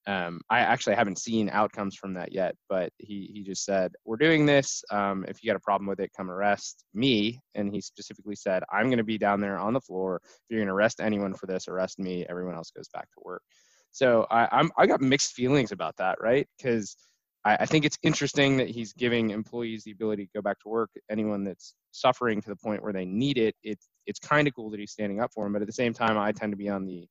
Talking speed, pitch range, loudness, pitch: 250 wpm, 100-115 Hz, -27 LUFS, 105 Hz